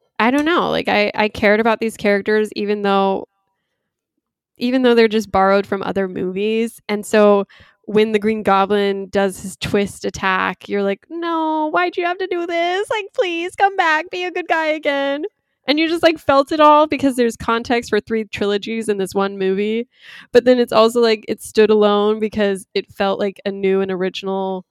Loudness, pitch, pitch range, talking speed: -17 LUFS, 215 Hz, 200-285 Hz, 195 wpm